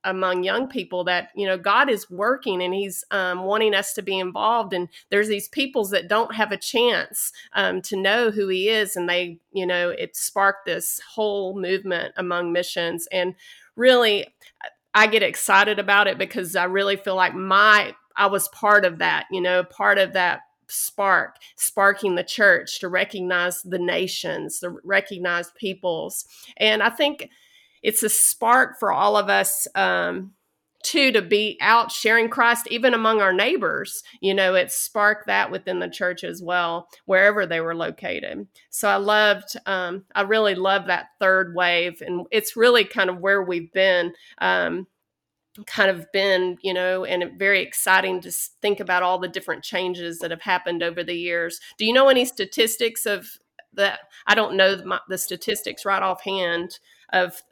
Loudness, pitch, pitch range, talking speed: -21 LUFS, 195 Hz, 180-210 Hz, 175 wpm